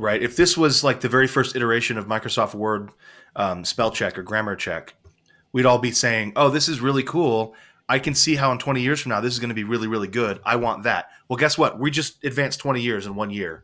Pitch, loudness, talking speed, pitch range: 125 Hz, -21 LUFS, 255 wpm, 110-140 Hz